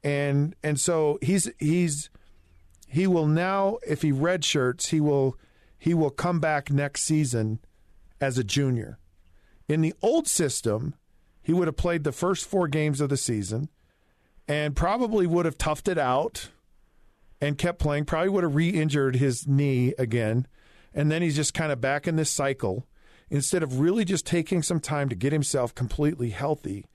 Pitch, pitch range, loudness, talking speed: 145 Hz, 125-165 Hz, -26 LUFS, 170 wpm